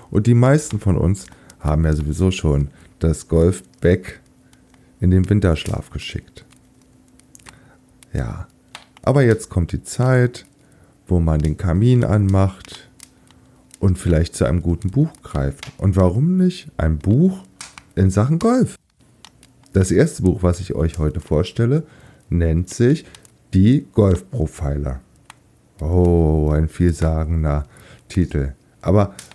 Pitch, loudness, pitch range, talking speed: 90 Hz, -19 LUFS, 80-115 Hz, 120 wpm